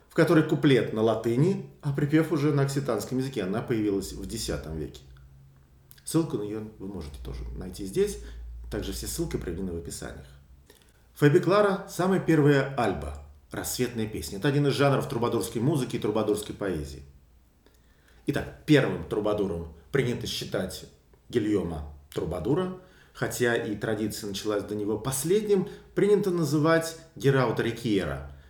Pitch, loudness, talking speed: 110 Hz, -27 LUFS, 135 wpm